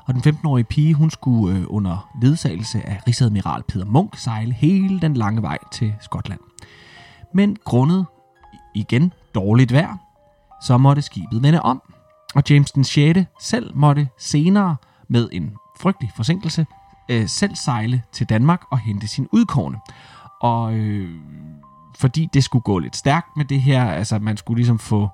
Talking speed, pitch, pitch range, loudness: 160 wpm, 125 Hz, 110-150 Hz, -19 LUFS